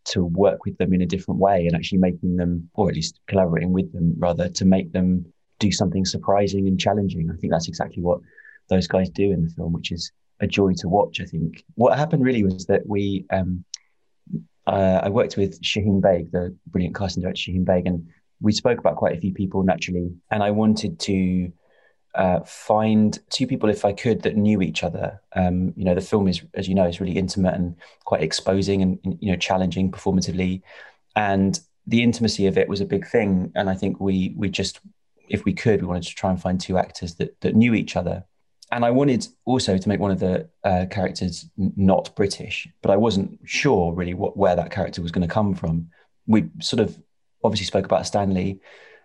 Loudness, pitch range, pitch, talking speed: -22 LUFS, 90-100 Hz, 95 Hz, 215 wpm